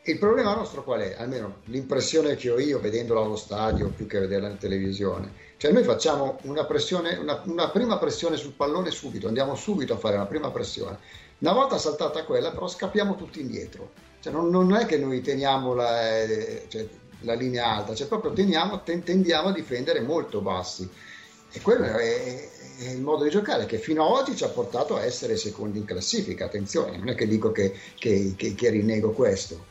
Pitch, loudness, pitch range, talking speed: 135 Hz, -26 LUFS, 110-175 Hz, 195 wpm